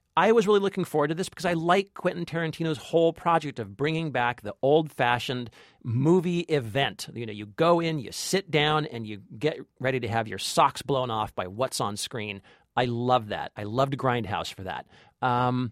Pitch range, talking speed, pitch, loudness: 120-165 Hz, 200 wpm, 135 Hz, -27 LUFS